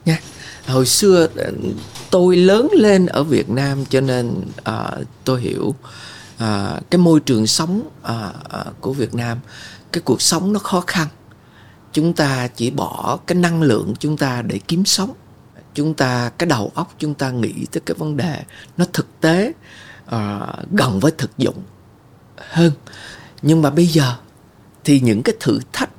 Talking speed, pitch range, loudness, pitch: 165 wpm, 120-165 Hz, -17 LUFS, 140 Hz